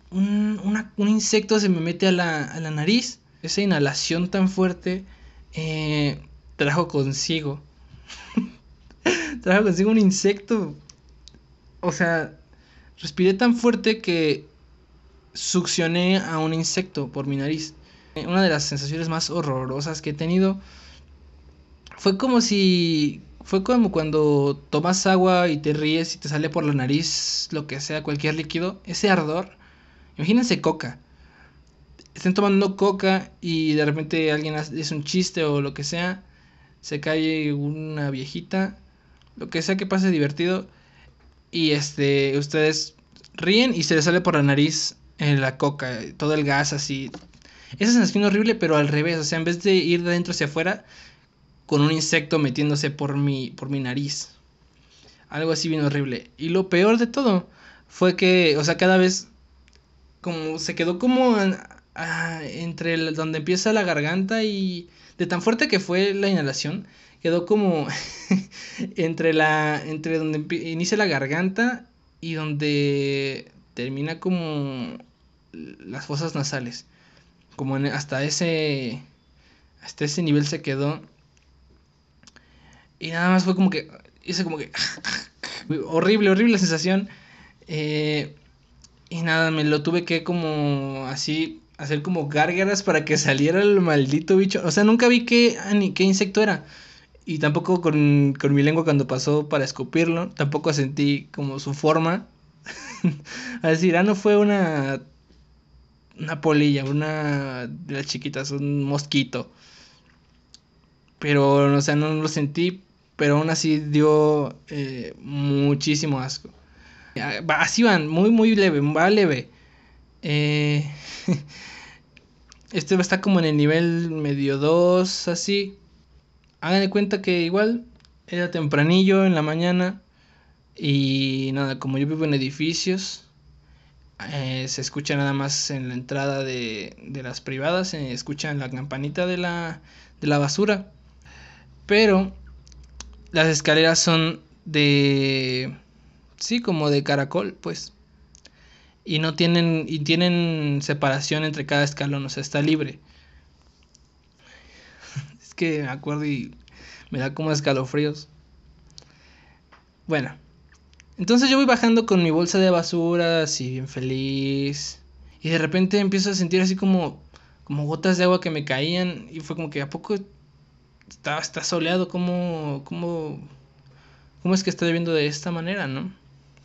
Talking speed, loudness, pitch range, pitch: 140 wpm, -22 LUFS, 140-180 Hz, 155 Hz